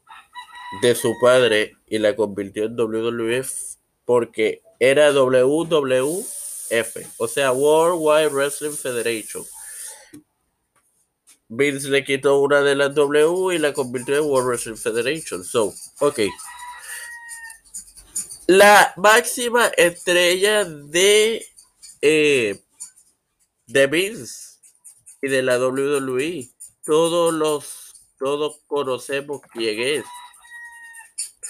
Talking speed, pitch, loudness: 95 wpm, 150 Hz, -19 LUFS